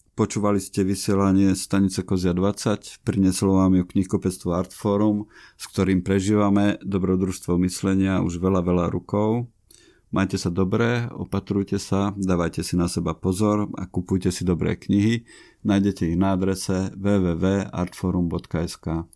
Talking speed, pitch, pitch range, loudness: 125 wpm, 95 Hz, 90-100 Hz, -23 LUFS